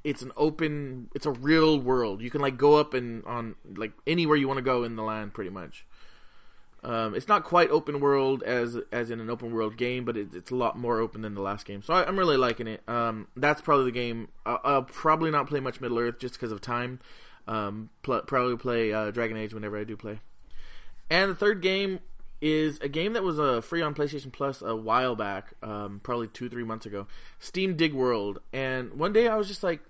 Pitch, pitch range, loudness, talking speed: 125 Hz, 110-150 Hz, -28 LUFS, 235 wpm